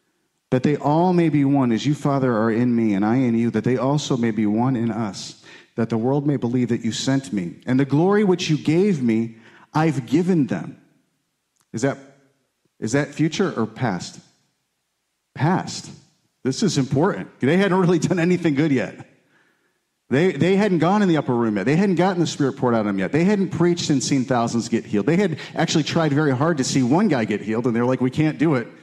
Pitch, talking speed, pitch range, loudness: 140 Hz, 225 wpm, 120-165 Hz, -20 LUFS